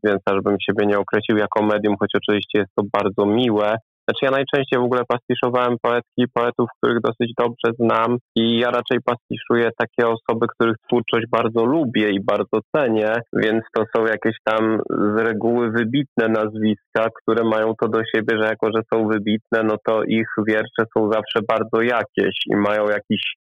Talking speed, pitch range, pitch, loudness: 175 wpm, 110-120 Hz, 115 Hz, -20 LUFS